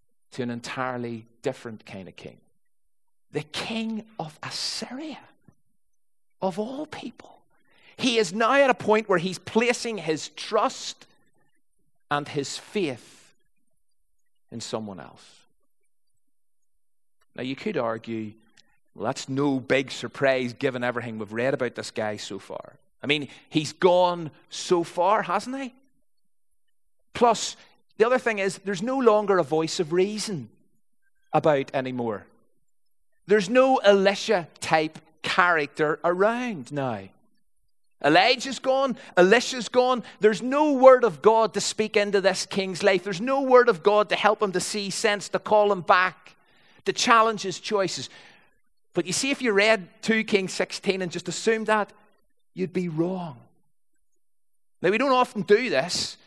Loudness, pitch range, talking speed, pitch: -24 LUFS, 155-230 Hz, 145 wpm, 200 Hz